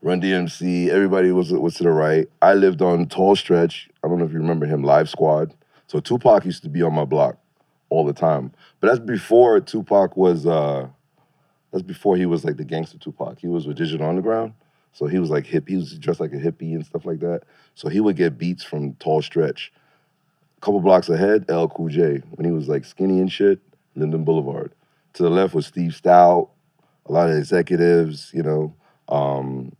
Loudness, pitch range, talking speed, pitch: -20 LUFS, 80-95 Hz, 205 wpm, 85 Hz